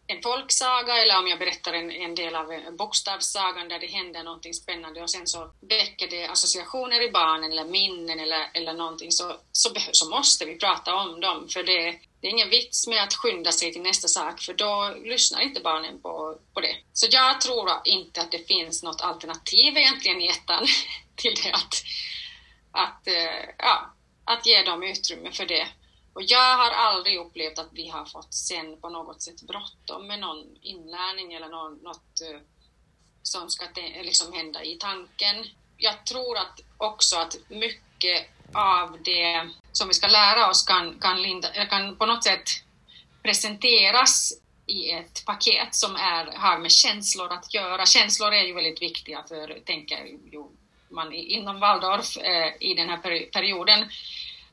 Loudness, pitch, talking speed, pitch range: -22 LUFS, 180 Hz, 165 wpm, 165-205 Hz